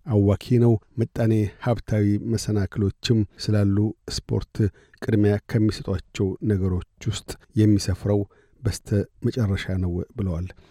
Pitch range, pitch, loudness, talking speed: 95-110 Hz, 105 Hz, -24 LUFS, 90 wpm